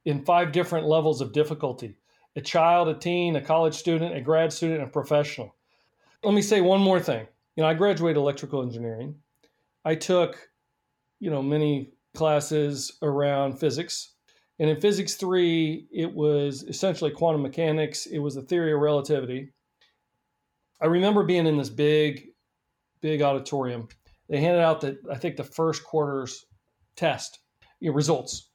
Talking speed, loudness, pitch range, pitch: 150 wpm, -25 LUFS, 140-165 Hz, 155 Hz